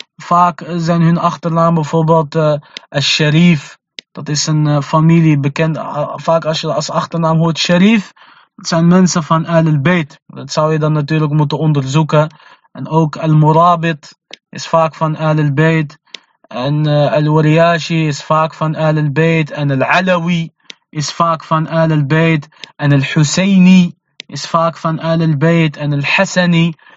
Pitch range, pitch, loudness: 150-165 Hz, 160 Hz, -13 LUFS